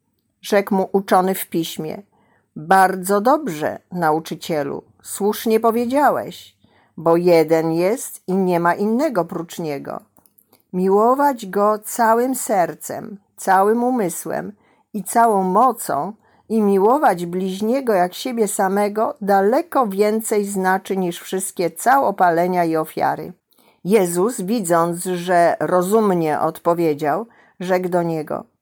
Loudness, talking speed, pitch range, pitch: -18 LUFS, 105 wpm, 175-220 Hz, 195 Hz